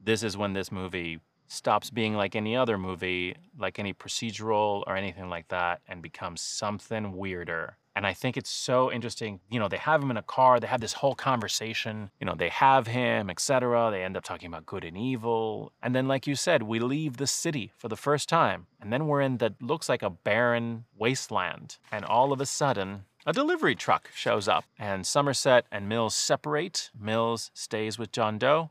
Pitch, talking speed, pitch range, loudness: 115 Hz, 205 wpm, 100-130 Hz, -28 LUFS